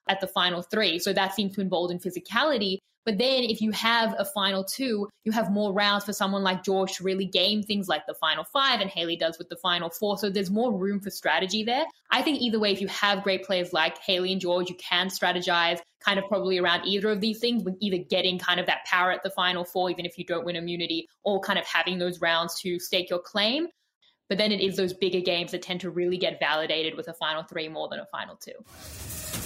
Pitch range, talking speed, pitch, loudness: 175-205 Hz, 250 wpm, 190 Hz, -26 LUFS